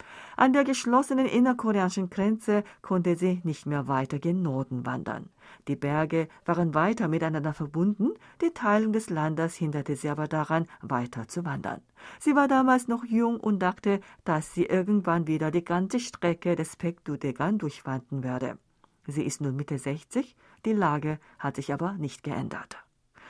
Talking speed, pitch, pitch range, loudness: 160 wpm, 170 Hz, 150-210 Hz, -28 LUFS